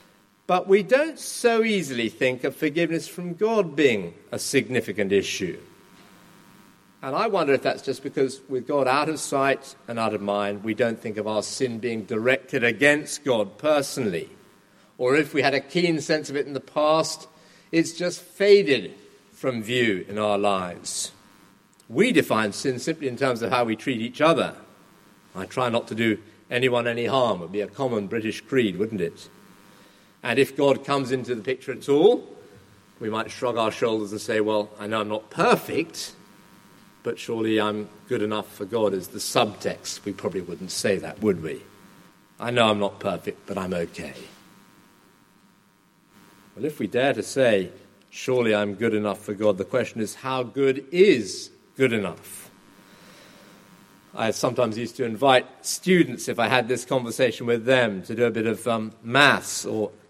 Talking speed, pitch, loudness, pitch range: 180 wpm, 120 Hz, -24 LUFS, 105-140 Hz